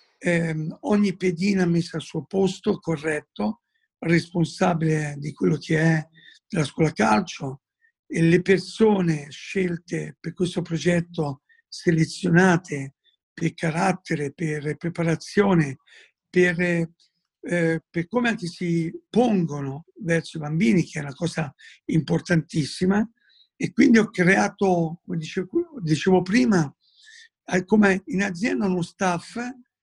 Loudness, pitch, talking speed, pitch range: -23 LUFS, 170 Hz, 110 wpm, 160-190 Hz